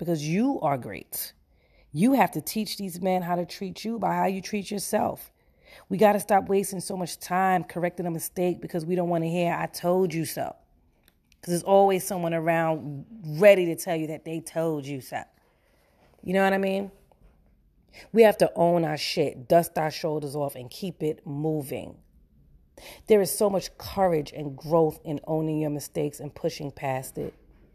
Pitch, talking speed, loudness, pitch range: 170 Hz, 185 wpm, -26 LUFS, 150-190 Hz